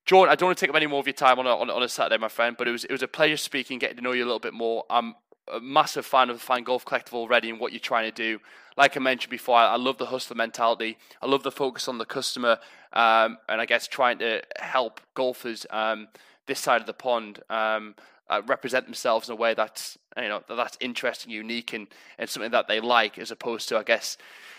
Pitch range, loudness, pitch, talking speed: 115-130 Hz, -25 LUFS, 120 Hz, 260 wpm